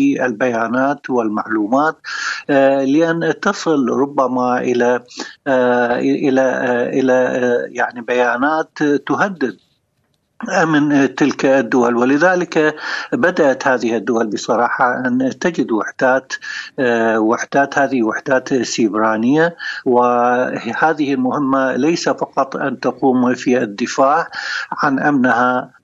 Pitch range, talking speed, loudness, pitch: 125-145 Hz, 85 wpm, -16 LUFS, 130 Hz